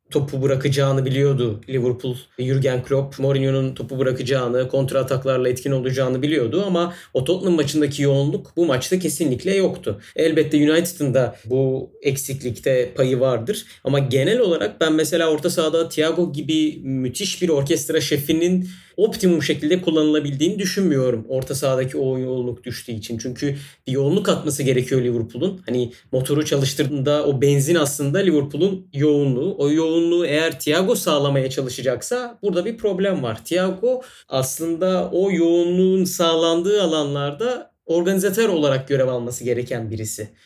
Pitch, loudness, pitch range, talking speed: 145 Hz, -20 LUFS, 130-170 Hz, 130 wpm